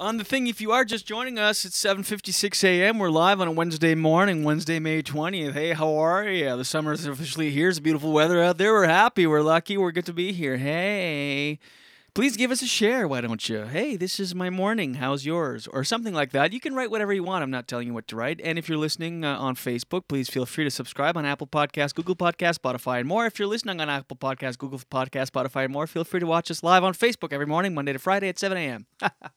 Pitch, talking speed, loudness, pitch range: 165 Hz, 255 wpm, -24 LUFS, 140-195 Hz